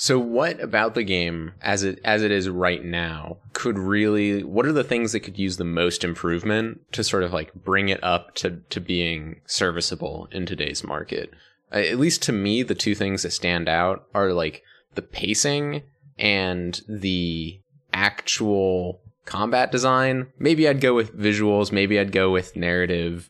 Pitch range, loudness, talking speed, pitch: 90-110 Hz, -23 LUFS, 175 wpm, 95 Hz